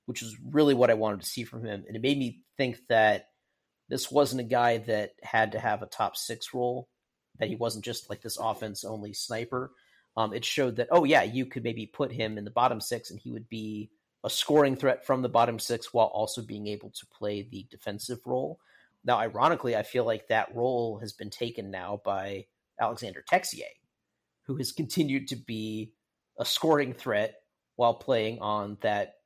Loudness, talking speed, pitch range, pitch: -29 LUFS, 200 wpm, 105-125 Hz, 115 Hz